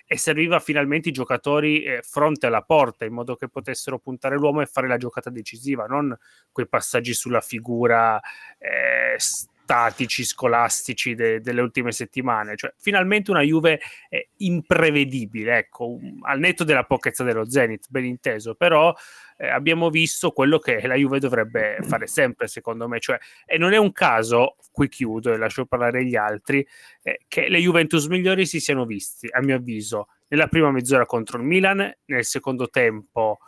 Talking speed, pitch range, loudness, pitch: 170 wpm, 120-155 Hz, -21 LUFS, 130 Hz